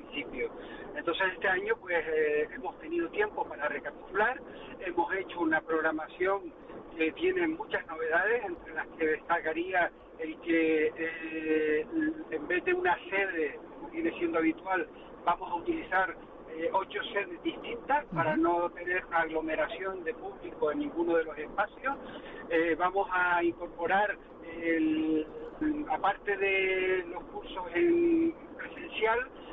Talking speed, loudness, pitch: 130 wpm, -31 LUFS, 185 Hz